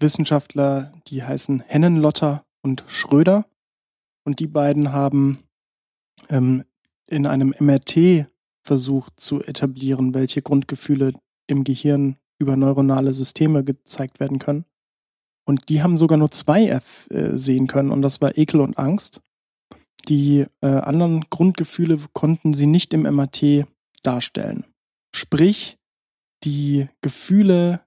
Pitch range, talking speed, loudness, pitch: 135-155 Hz, 120 wpm, -19 LUFS, 145 Hz